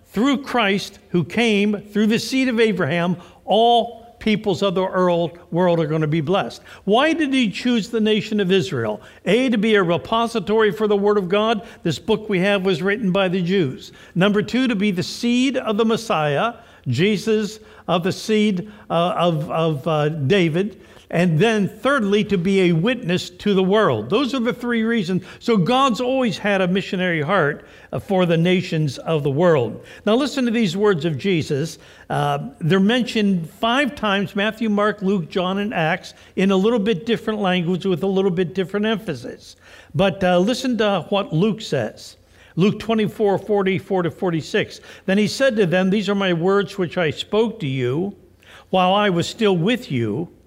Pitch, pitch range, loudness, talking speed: 195 Hz, 180-220 Hz, -20 LUFS, 185 wpm